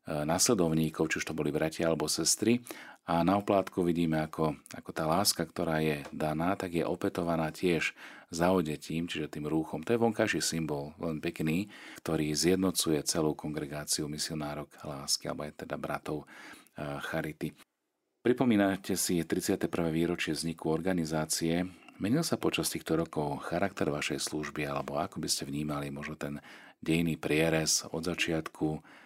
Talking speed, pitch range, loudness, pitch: 140 wpm, 75-85 Hz, -31 LUFS, 80 Hz